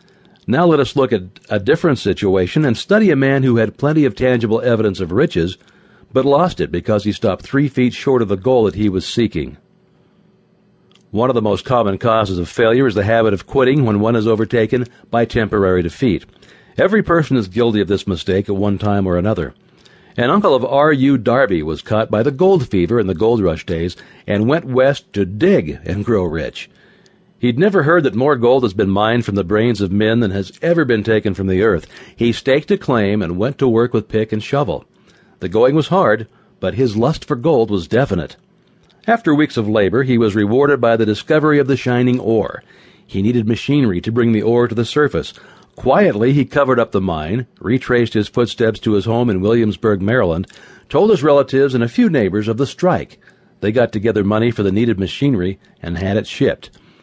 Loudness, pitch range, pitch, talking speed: -16 LUFS, 105-135 Hz, 115 Hz, 210 wpm